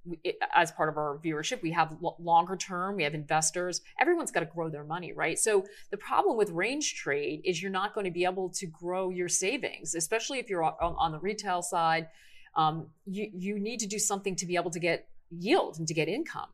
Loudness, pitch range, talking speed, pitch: -30 LUFS, 165-205 Hz, 220 wpm, 180 Hz